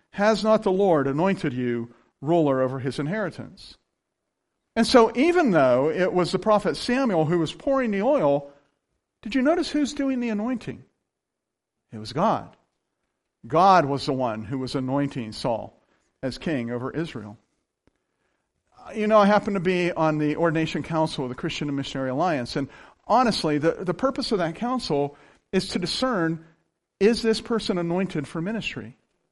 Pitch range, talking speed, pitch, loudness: 140-215 Hz, 160 wpm, 165 Hz, -24 LUFS